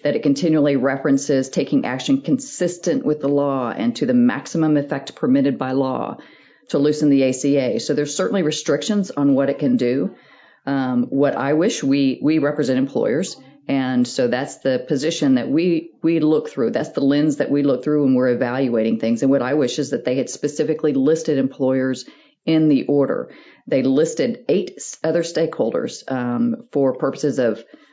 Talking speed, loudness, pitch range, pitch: 180 wpm, -19 LUFS, 135-160 Hz, 145 Hz